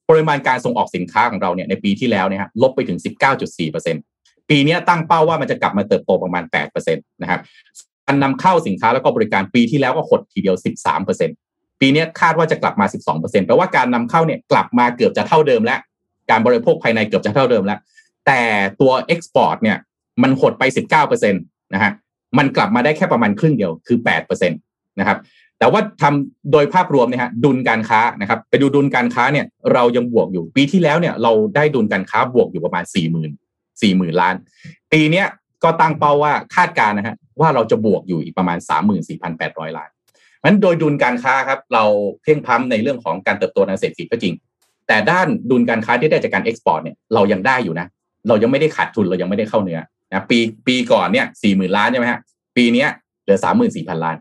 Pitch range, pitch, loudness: 120-170 Hz, 145 Hz, -16 LUFS